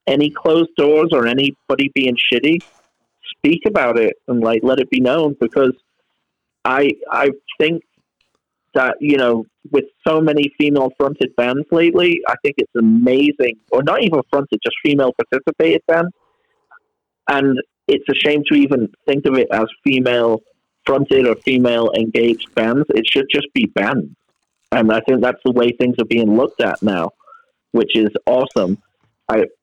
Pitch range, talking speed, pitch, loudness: 120-165 Hz, 160 wpm, 140 Hz, -16 LUFS